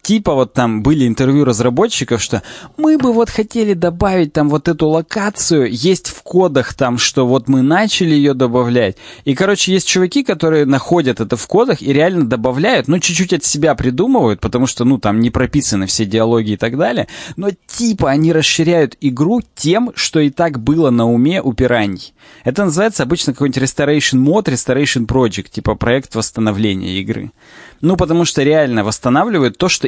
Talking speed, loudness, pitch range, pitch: 175 wpm, -14 LUFS, 125-175 Hz, 145 Hz